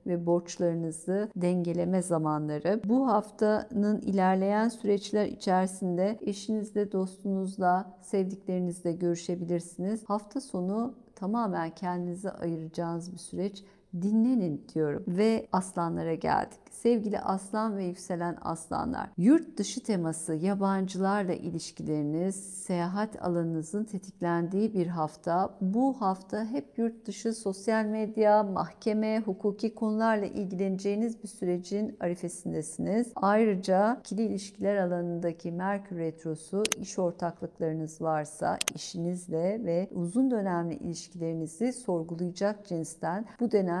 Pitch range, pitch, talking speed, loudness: 175-210 Hz, 190 Hz, 100 wpm, -30 LUFS